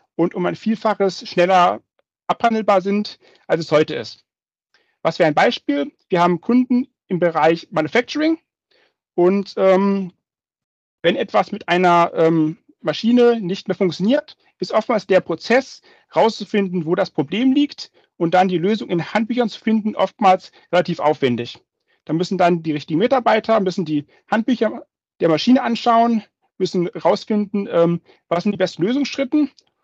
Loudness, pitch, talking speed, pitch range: -18 LUFS, 195 Hz, 145 wpm, 175-235 Hz